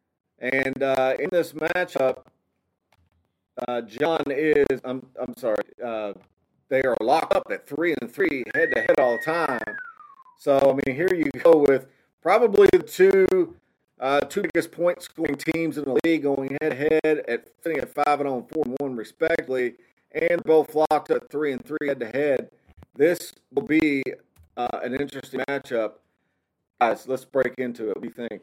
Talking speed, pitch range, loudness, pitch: 175 wpm, 130-165 Hz, -23 LUFS, 145 Hz